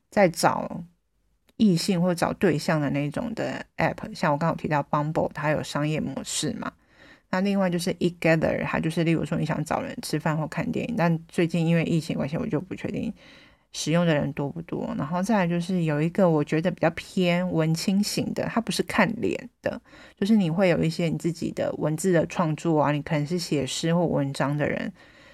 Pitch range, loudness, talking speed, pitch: 155-185 Hz, -25 LUFS, 320 characters per minute, 170 Hz